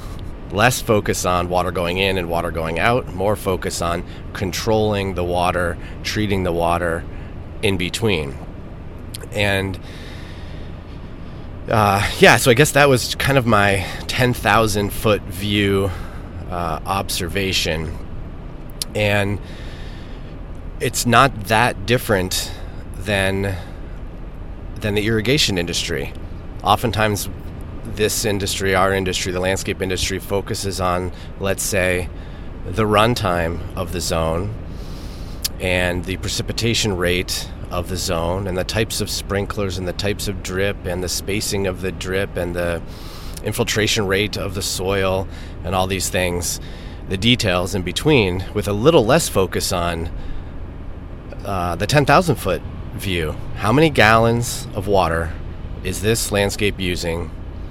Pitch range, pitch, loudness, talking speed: 85-105 Hz, 95 Hz, -19 LUFS, 130 wpm